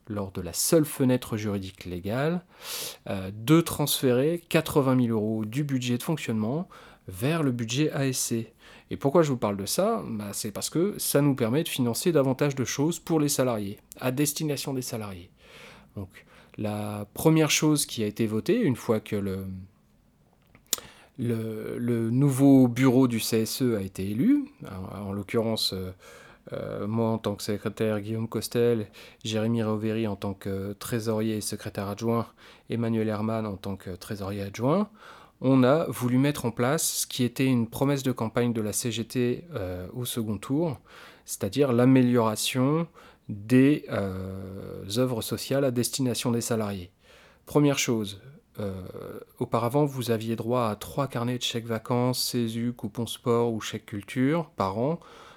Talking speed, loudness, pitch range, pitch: 160 wpm, -27 LUFS, 105-135 Hz, 115 Hz